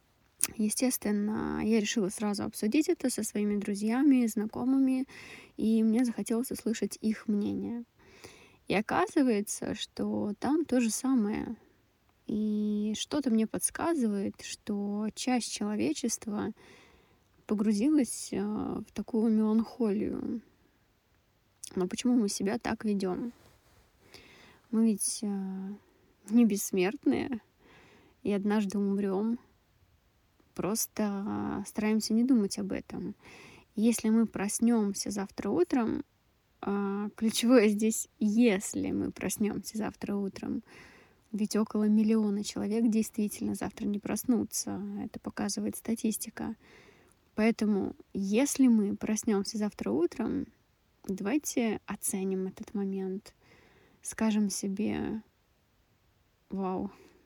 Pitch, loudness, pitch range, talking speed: 215 Hz, -31 LUFS, 200-235 Hz, 95 wpm